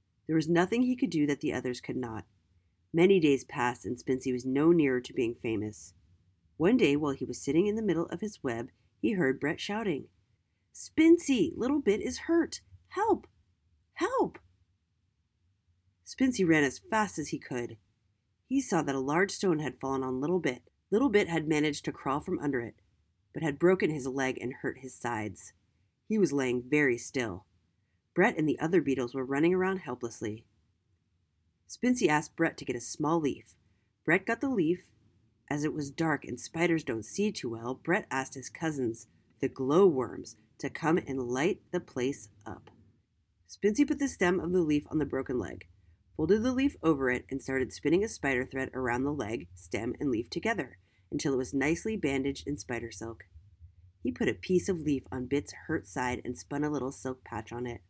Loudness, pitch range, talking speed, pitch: -30 LUFS, 105-165 Hz, 190 wpm, 130 Hz